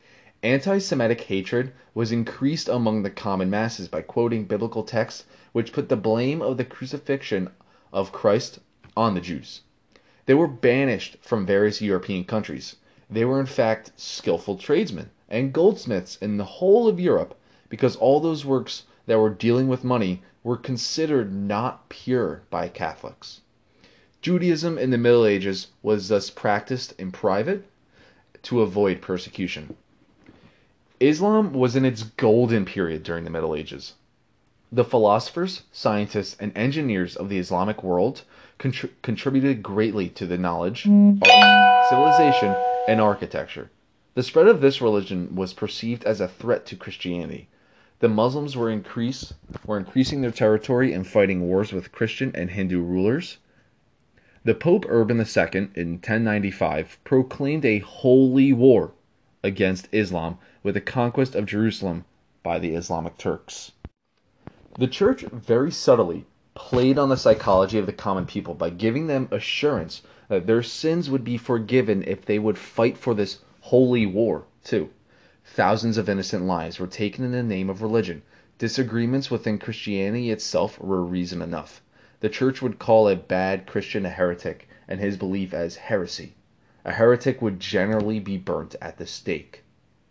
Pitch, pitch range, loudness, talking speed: 110 Hz, 95-130 Hz, -22 LUFS, 150 wpm